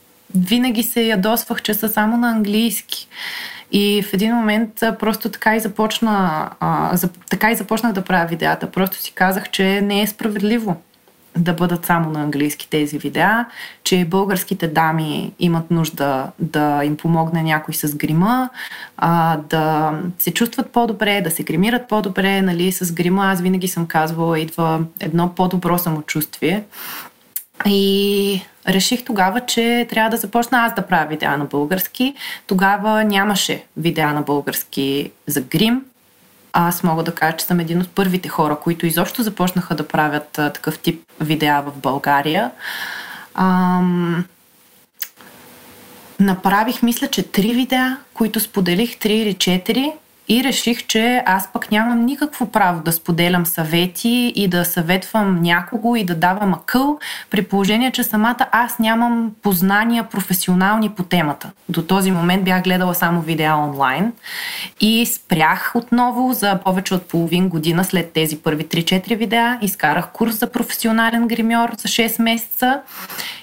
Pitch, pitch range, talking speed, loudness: 195 Hz, 170-230 Hz, 145 wpm, -18 LUFS